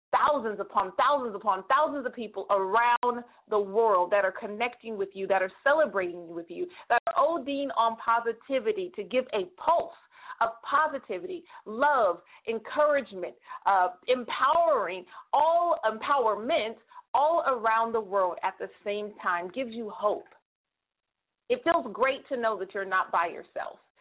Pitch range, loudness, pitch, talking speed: 205-290 Hz, -28 LUFS, 230 Hz, 145 wpm